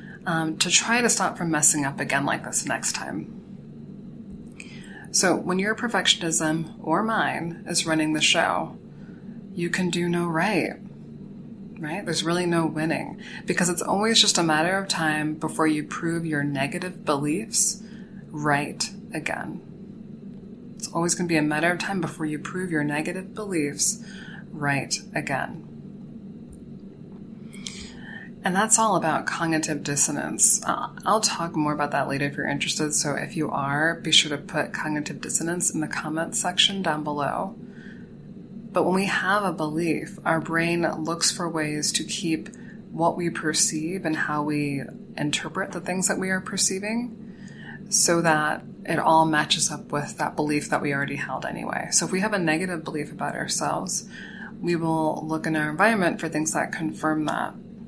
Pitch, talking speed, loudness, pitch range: 170 Hz, 165 wpm, -24 LUFS, 155-205 Hz